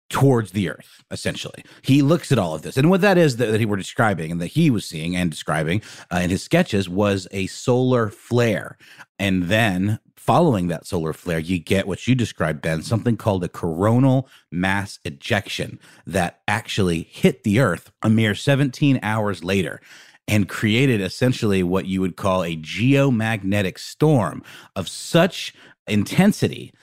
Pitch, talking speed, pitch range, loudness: 105 Hz, 170 wpm, 90-125 Hz, -21 LUFS